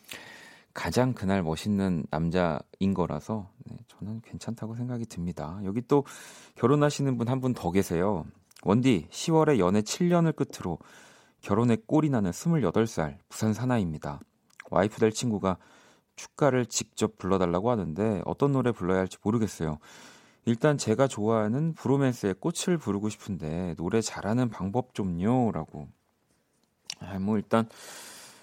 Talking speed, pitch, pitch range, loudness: 290 characters per minute, 110 Hz, 95-125 Hz, -28 LUFS